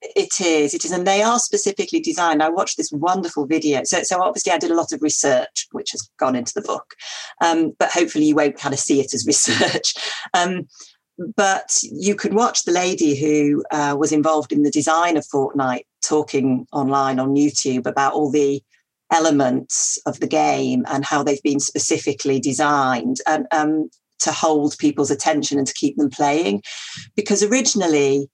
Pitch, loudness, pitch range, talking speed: 150 Hz, -19 LUFS, 140-175 Hz, 180 wpm